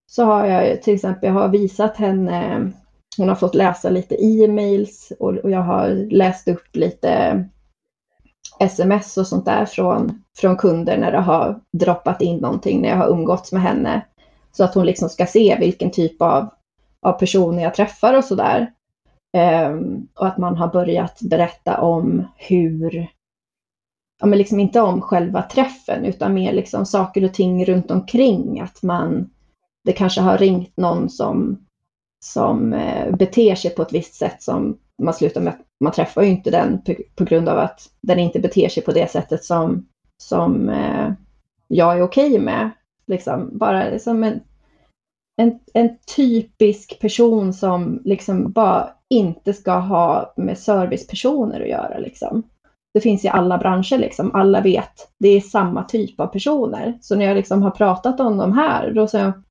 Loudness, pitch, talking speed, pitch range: -18 LUFS, 195 Hz, 170 wpm, 180-220 Hz